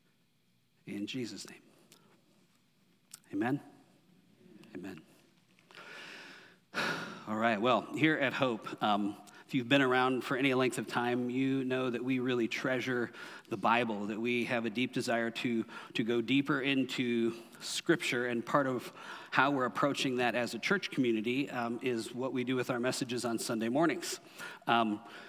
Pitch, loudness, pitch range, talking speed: 125 Hz, -33 LUFS, 115-130 Hz, 150 wpm